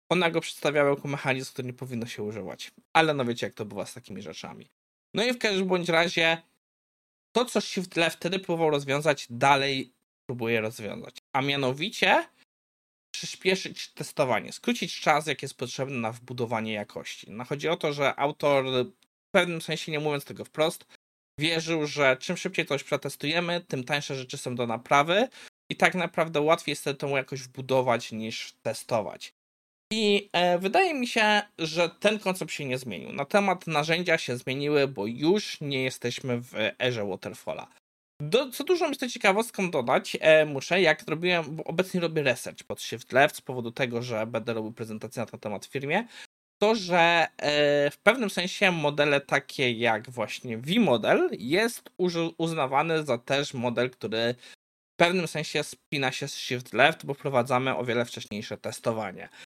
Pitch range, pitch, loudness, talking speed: 125-175 Hz, 145 Hz, -27 LUFS, 165 wpm